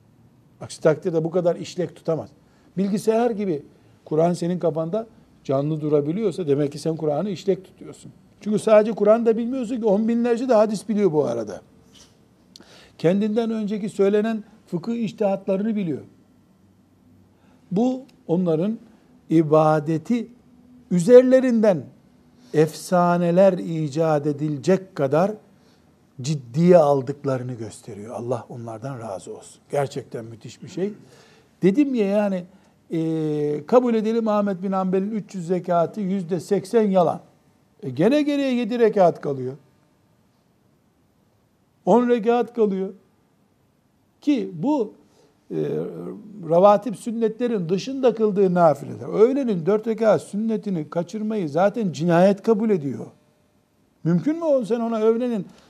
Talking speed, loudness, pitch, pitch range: 110 wpm, -21 LUFS, 190 Hz, 155-220 Hz